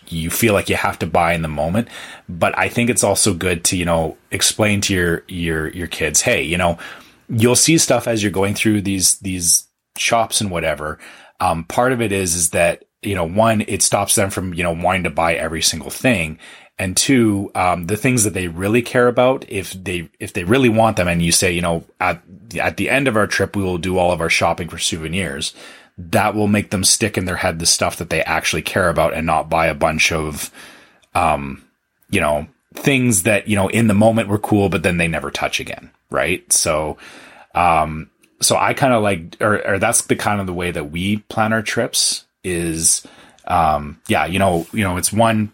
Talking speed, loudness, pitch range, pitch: 225 wpm, -17 LUFS, 85-110 Hz, 95 Hz